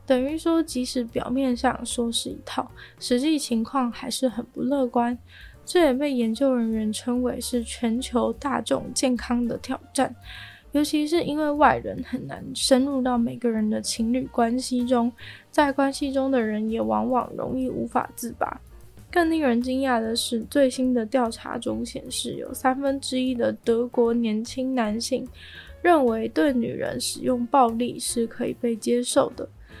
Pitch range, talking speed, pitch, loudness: 235-270 Hz, 240 characters per minute, 250 Hz, -24 LUFS